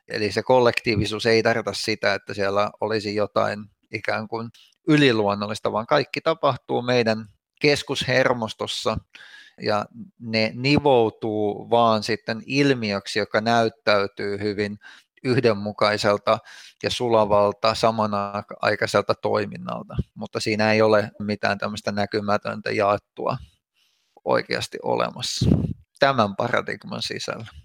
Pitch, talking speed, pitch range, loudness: 110 Hz, 100 wpm, 105-115 Hz, -23 LUFS